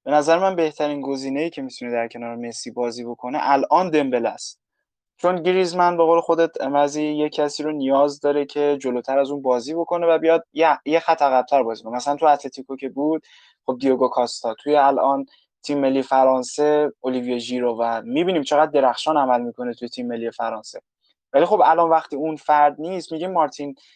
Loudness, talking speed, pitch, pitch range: -20 LUFS, 185 wpm, 140 Hz, 125-155 Hz